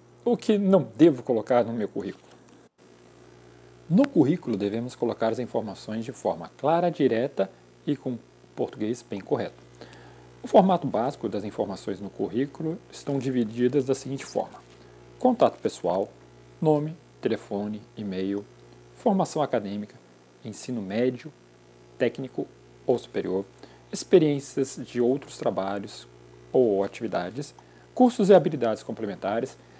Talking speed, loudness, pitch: 115 wpm, -26 LUFS, 105 Hz